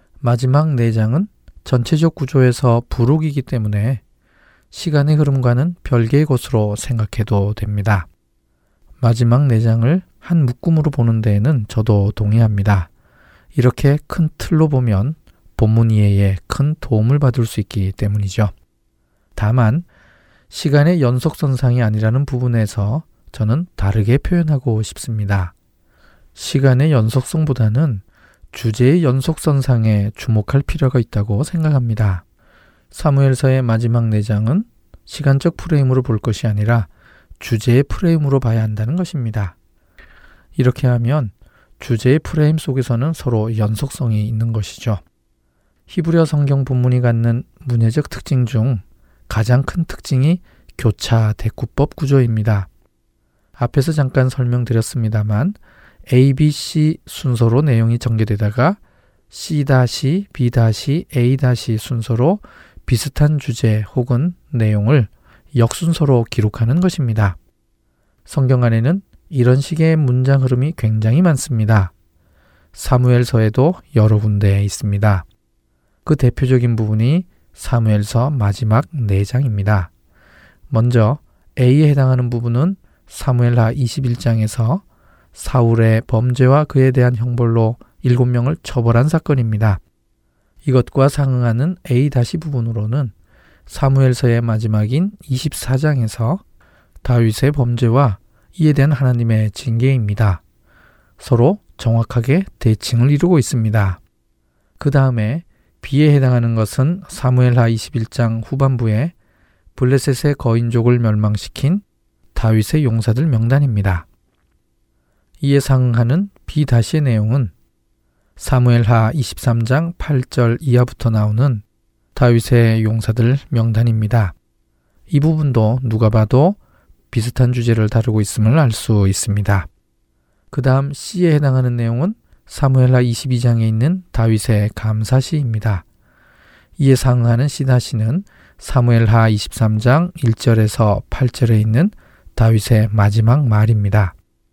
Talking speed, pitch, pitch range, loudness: 260 characters per minute, 120 Hz, 110-135 Hz, -16 LUFS